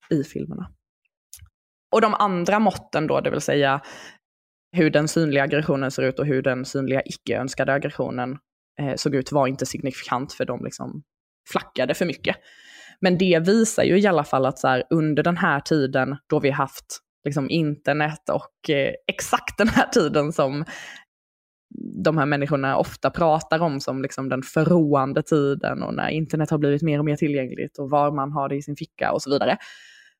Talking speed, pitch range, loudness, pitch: 180 wpm, 135-160 Hz, -22 LUFS, 145 Hz